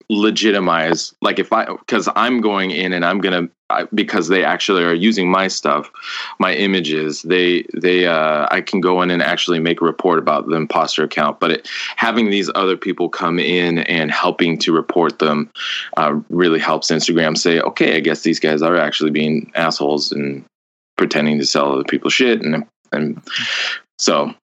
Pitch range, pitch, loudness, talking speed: 75-95 Hz, 85 Hz, -16 LUFS, 180 wpm